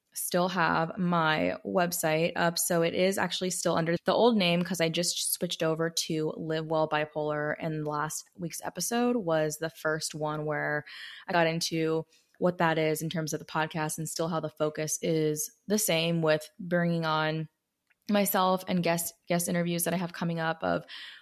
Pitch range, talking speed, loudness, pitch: 155-175 Hz, 185 wpm, -29 LUFS, 165 Hz